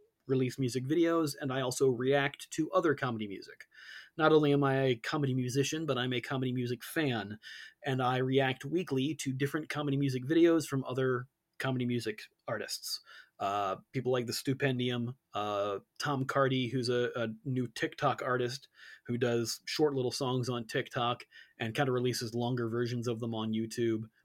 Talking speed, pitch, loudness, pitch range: 170 wpm, 130 Hz, -33 LUFS, 120-140 Hz